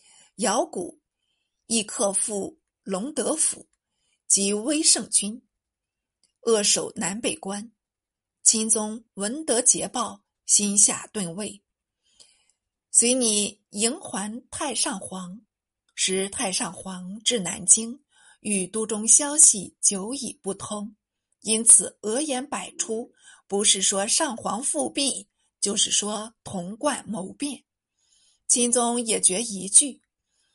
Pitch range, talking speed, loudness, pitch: 200-255 Hz, 150 characters per minute, -21 LUFS, 220 Hz